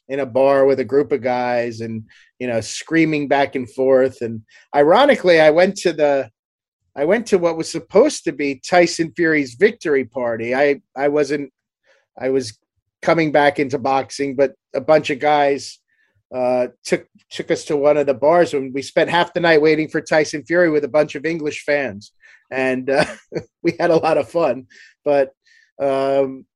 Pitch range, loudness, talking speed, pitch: 130-160 Hz, -18 LUFS, 185 wpm, 145 Hz